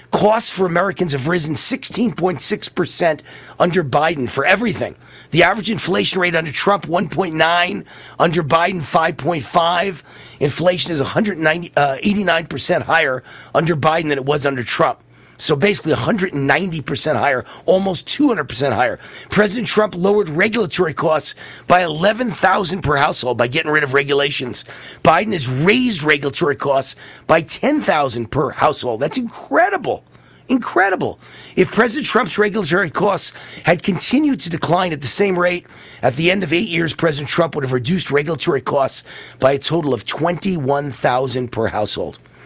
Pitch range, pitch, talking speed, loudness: 145-195 Hz, 170 Hz, 140 wpm, -17 LUFS